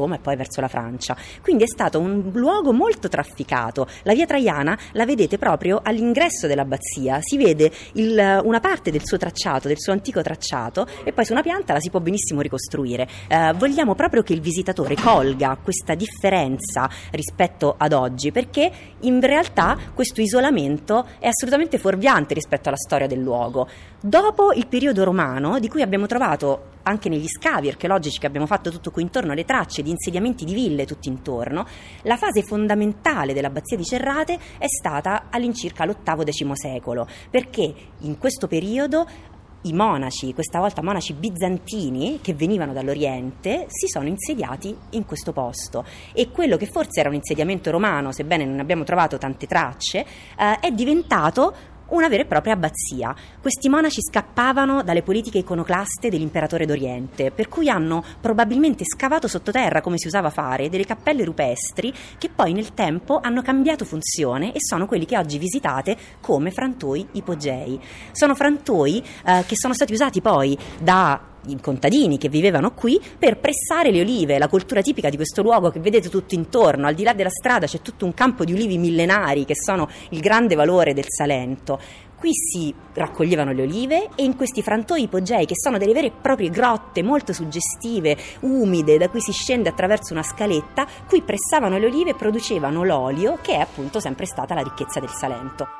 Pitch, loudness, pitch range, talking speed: 185 Hz, -21 LUFS, 150-235 Hz, 170 wpm